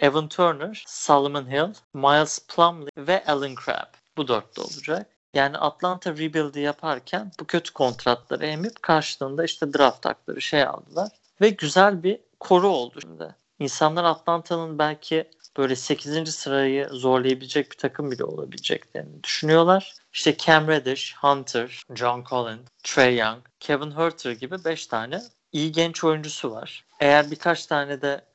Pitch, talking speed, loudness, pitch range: 150 Hz, 140 wpm, -23 LUFS, 140-165 Hz